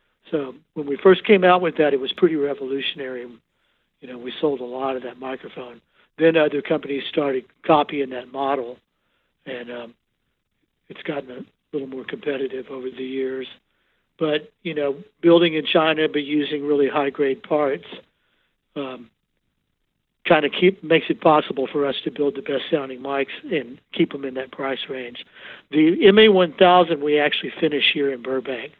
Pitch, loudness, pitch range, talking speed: 145 Hz, -20 LUFS, 130-160 Hz, 165 wpm